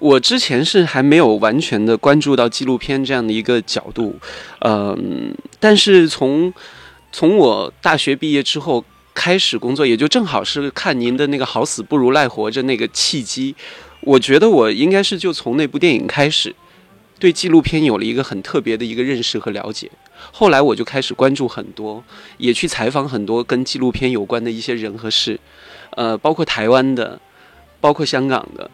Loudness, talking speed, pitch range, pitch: -15 LUFS, 280 characters per minute, 120-160 Hz, 135 Hz